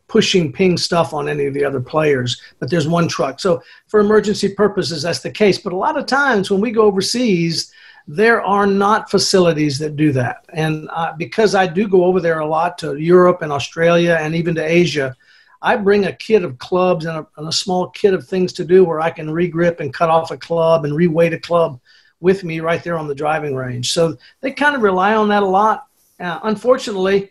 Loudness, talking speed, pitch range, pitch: -16 LUFS, 225 wpm, 160-200 Hz, 175 Hz